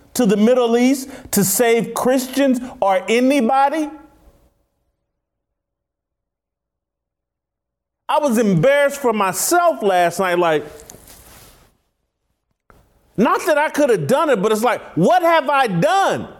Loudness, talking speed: -16 LUFS, 115 wpm